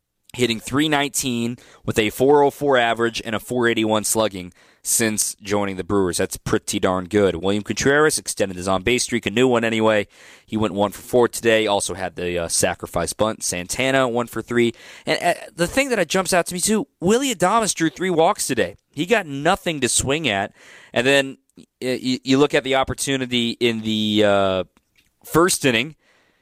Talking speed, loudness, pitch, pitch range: 180 wpm, -20 LUFS, 120 Hz, 105-140 Hz